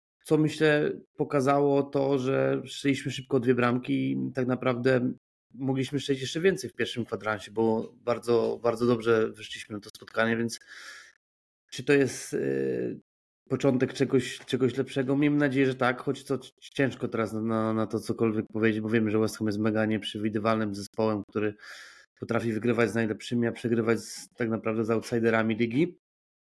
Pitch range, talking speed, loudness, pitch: 110-135 Hz, 160 wpm, -28 LUFS, 120 Hz